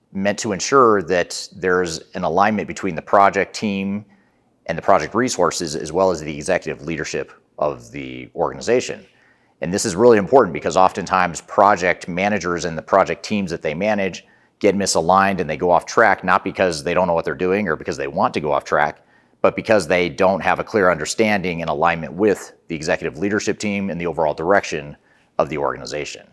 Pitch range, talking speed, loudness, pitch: 85-100 Hz, 195 wpm, -19 LUFS, 95 Hz